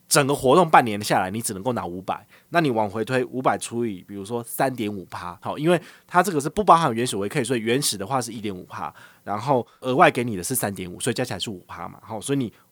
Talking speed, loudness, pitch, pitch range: 380 characters per minute, -23 LUFS, 120 Hz, 100-135 Hz